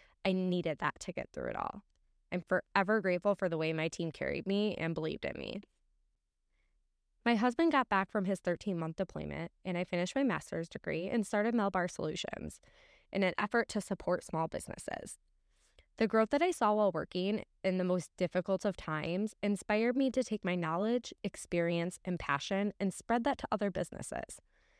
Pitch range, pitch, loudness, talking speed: 180-215 Hz, 195 Hz, -35 LUFS, 185 wpm